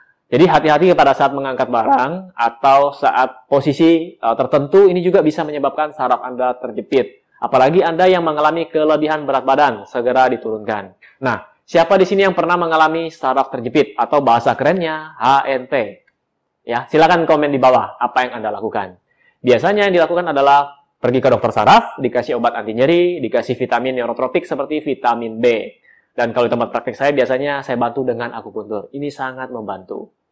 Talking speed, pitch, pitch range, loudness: 160 wpm, 140 Hz, 125-160 Hz, -16 LUFS